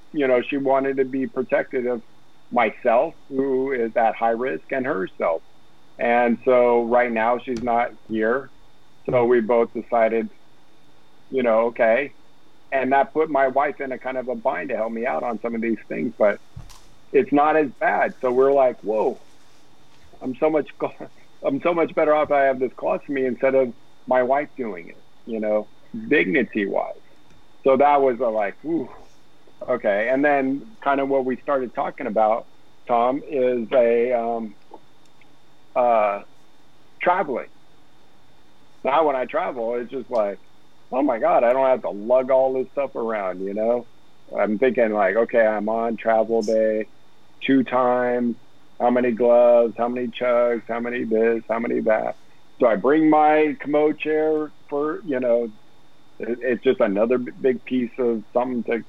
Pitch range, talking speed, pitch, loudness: 115-135 Hz, 170 wpm, 125 Hz, -21 LUFS